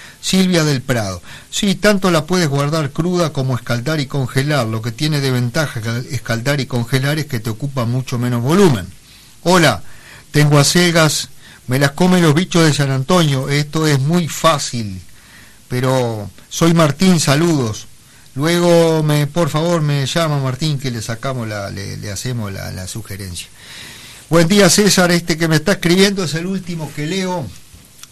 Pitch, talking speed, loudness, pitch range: 140 Hz, 165 wpm, -16 LUFS, 120-165 Hz